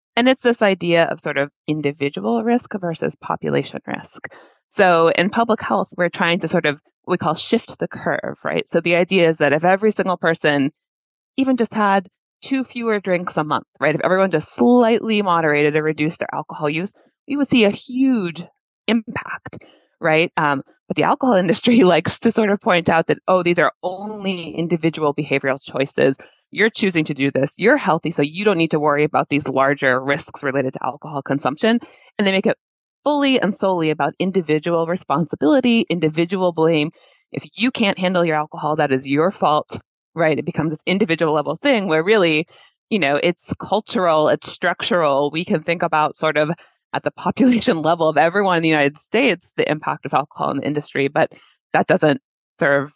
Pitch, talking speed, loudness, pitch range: 170 Hz, 190 wpm, -19 LUFS, 150-205 Hz